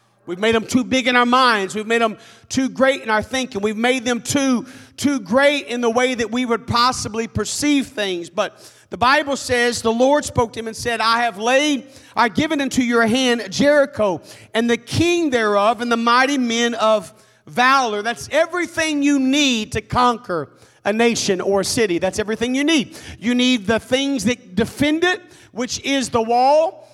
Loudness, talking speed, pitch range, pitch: -18 LUFS, 195 wpm, 225-270 Hz, 240 Hz